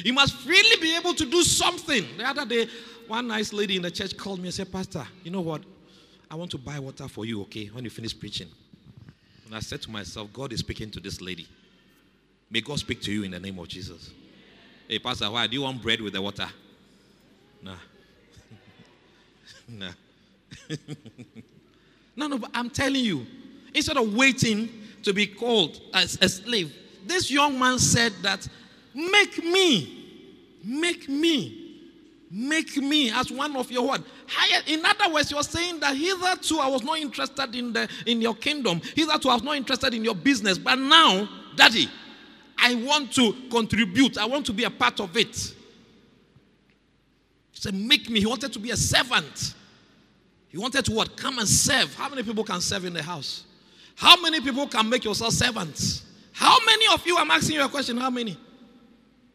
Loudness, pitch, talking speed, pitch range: -23 LUFS, 230 Hz, 190 wpm, 165-280 Hz